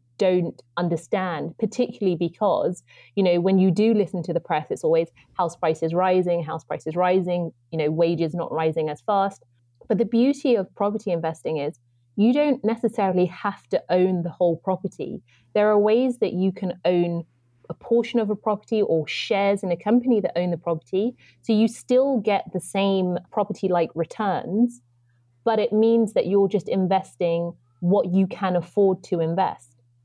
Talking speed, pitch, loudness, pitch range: 175 wpm, 185 Hz, -23 LUFS, 170-210 Hz